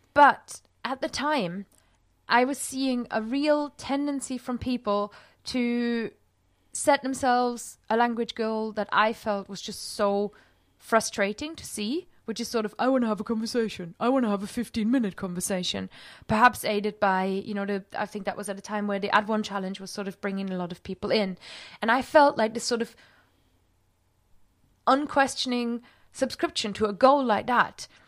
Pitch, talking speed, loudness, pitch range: 220 Hz, 185 wpm, -27 LUFS, 200-250 Hz